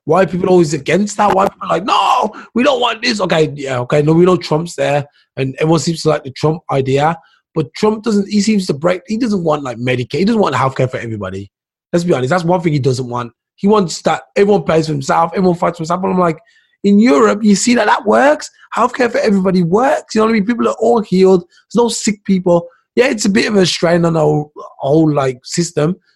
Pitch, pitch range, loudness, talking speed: 175 Hz, 150-205 Hz, -14 LUFS, 250 wpm